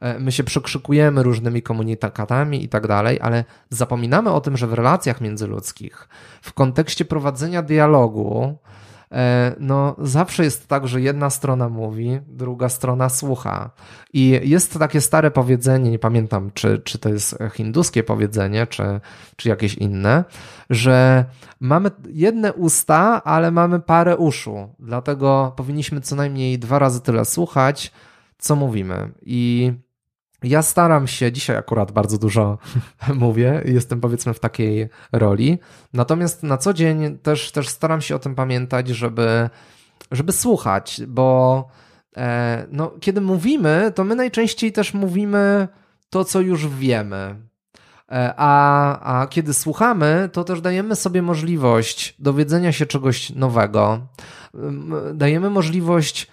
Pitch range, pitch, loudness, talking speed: 115-155 Hz, 130 Hz, -19 LUFS, 130 wpm